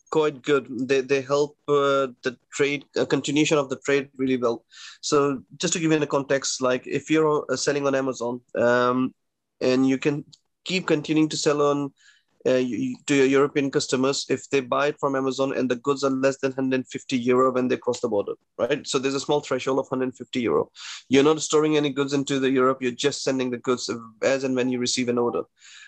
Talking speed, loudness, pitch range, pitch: 215 wpm, -24 LUFS, 130-145 Hz, 140 Hz